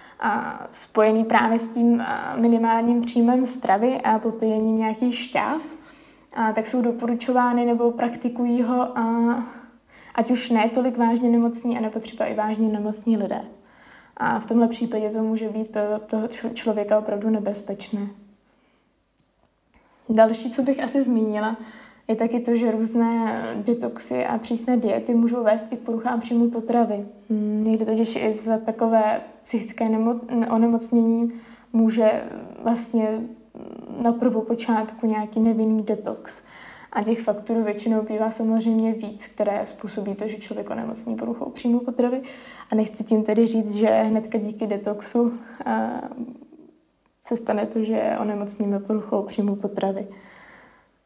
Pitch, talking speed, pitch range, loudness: 225 Hz, 130 wpm, 215-240 Hz, -23 LUFS